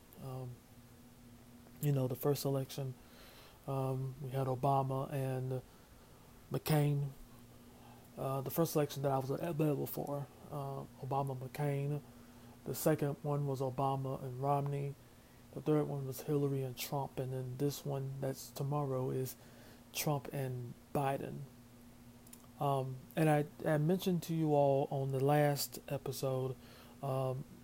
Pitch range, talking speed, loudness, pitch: 125-145 Hz, 130 wpm, -37 LUFS, 135 Hz